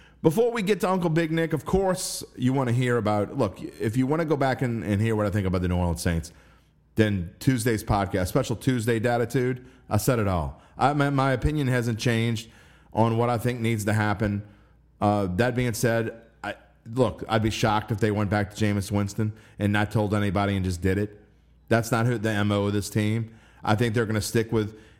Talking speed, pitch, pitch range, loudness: 225 wpm, 110 Hz, 105-125 Hz, -25 LUFS